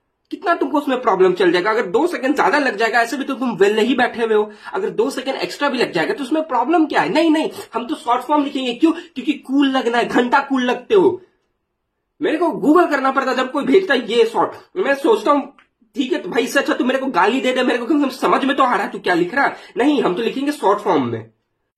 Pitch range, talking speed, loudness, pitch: 250-340 Hz, 260 wpm, -17 LUFS, 280 Hz